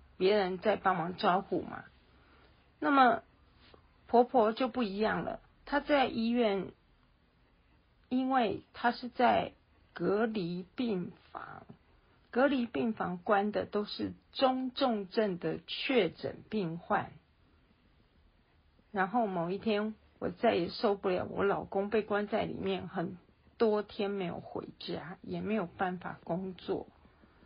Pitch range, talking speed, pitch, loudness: 180-230 Hz, 175 characters per minute, 200 Hz, -33 LUFS